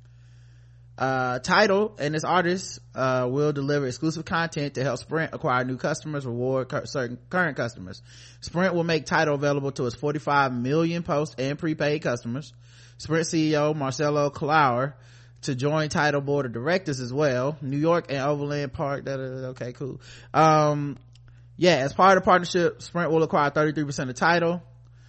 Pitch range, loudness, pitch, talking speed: 125-155 Hz, -24 LUFS, 145 Hz, 165 wpm